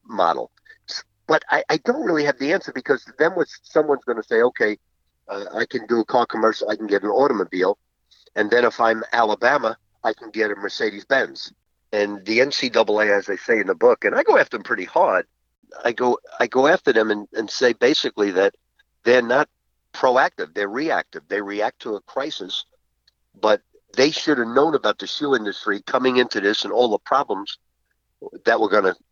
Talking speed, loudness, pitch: 200 wpm, -20 LUFS, 130 Hz